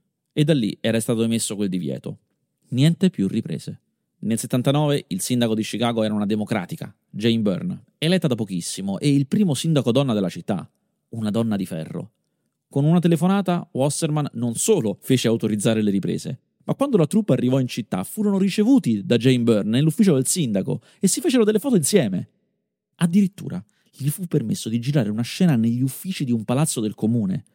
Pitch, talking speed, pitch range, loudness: 140 Hz, 180 wpm, 115-185 Hz, -21 LUFS